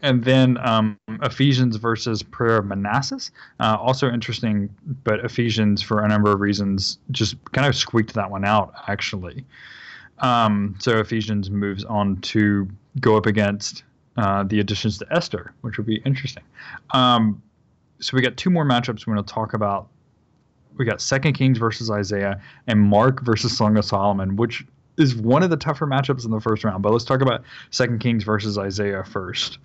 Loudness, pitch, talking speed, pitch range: -21 LUFS, 110 Hz, 180 wpm, 105-125 Hz